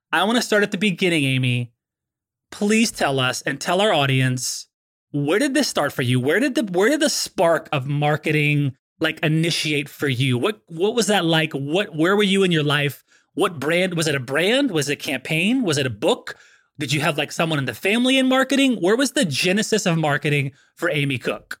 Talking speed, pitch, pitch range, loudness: 220 wpm, 160 Hz, 145-205 Hz, -20 LUFS